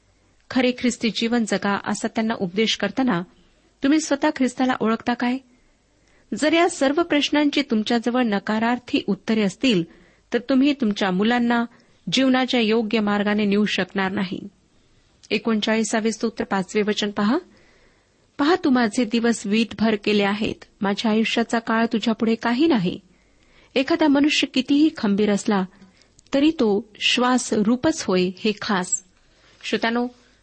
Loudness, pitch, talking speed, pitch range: -21 LUFS, 230 Hz, 120 wpm, 210-255 Hz